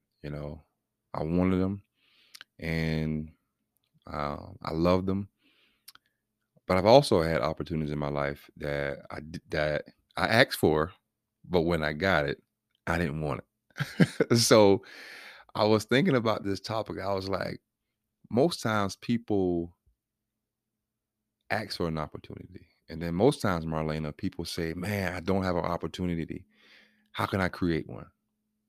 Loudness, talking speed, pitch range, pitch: -28 LUFS, 140 wpm, 80-110 Hz, 90 Hz